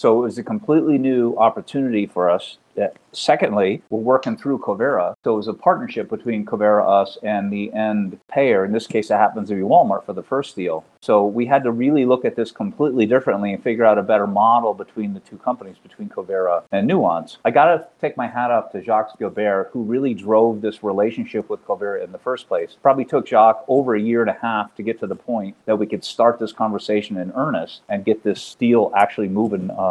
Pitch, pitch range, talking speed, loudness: 110 Hz, 105-130 Hz, 225 wpm, -19 LUFS